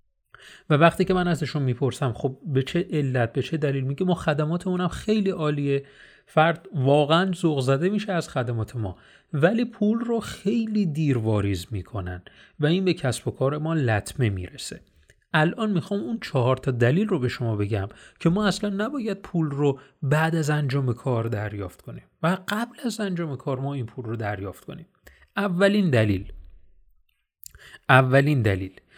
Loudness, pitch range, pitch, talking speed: -24 LUFS, 115-180 Hz, 145 Hz, 160 wpm